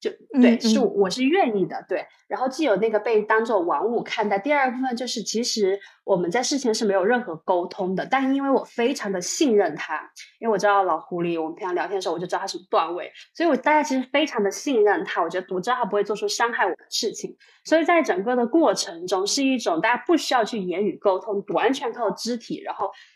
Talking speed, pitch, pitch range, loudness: 360 characters per minute, 230 Hz, 200-275 Hz, -23 LUFS